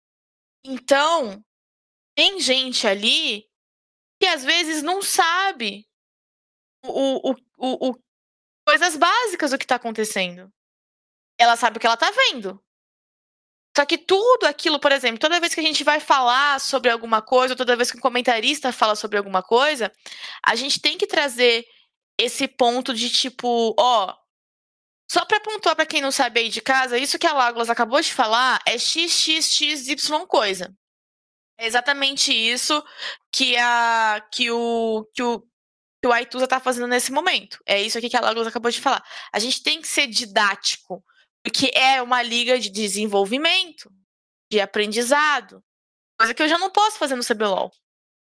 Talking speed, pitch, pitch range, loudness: 165 wpm, 255 Hz, 230-300 Hz, -20 LUFS